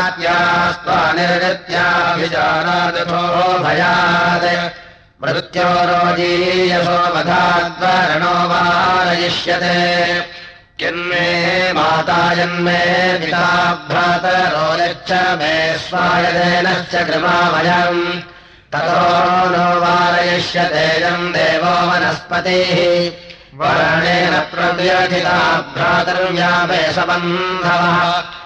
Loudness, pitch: -14 LUFS, 175 Hz